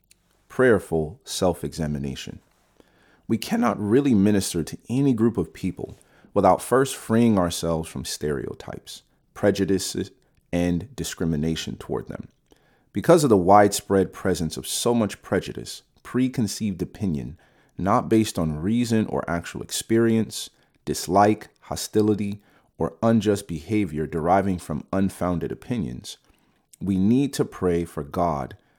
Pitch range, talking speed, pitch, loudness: 85-105 Hz, 115 wpm, 95 Hz, -23 LUFS